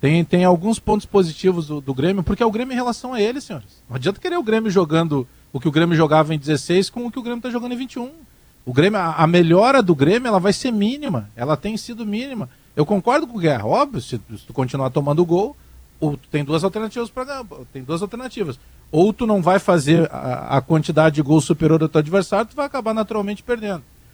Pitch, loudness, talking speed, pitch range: 180 Hz, -19 LUFS, 230 wpm, 155-220 Hz